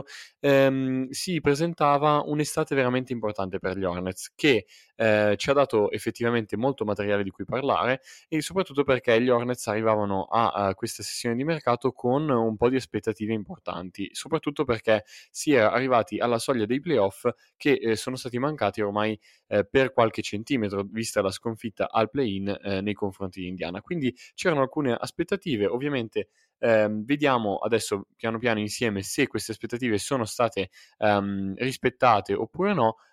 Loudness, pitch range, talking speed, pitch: -26 LUFS, 105-135 Hz, 160 wpm, 115 Hz